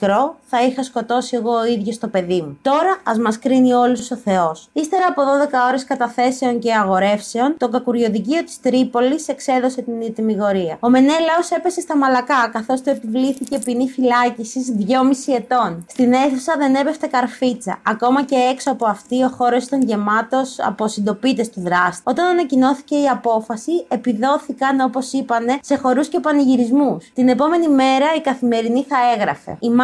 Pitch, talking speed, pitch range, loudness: 255 Hz, 155 wpm, 235-275 Hz, -17 LUFS